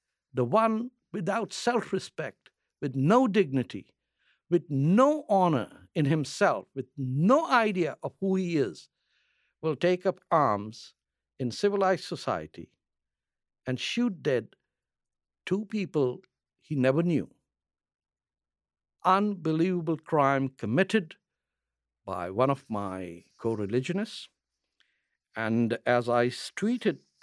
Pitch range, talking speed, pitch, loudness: 120-195 Hz, 105 wpm, 160 Hz, -28 LUFS